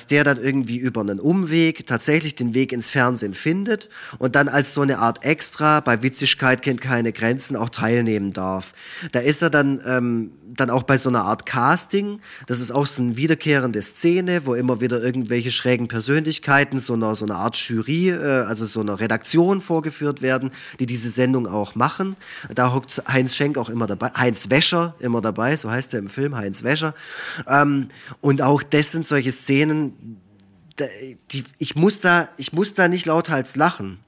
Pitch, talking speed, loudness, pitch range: 130 Hz, 185 wpm, -19 LUFS, 120-150 Hz